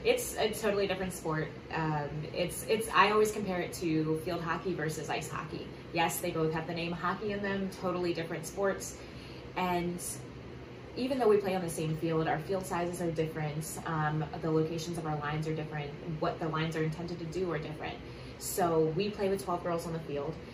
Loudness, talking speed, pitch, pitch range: -33 LUFS, 205 wpm, 170 Hz, 155-180 Hz